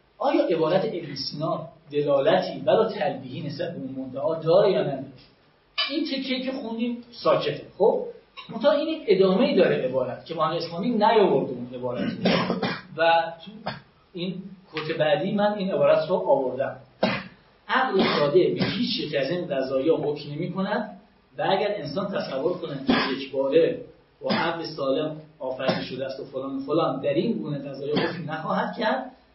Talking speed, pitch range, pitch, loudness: 155 wpm, 140-215 Hz, 170 Hz, -25 LUFS